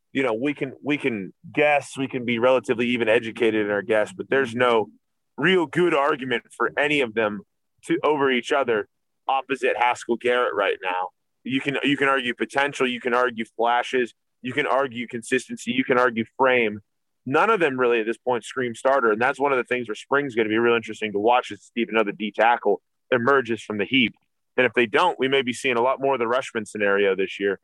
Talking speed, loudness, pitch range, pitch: 225 wpm, -22 LUFS, 115-135 Hz, 125 Hz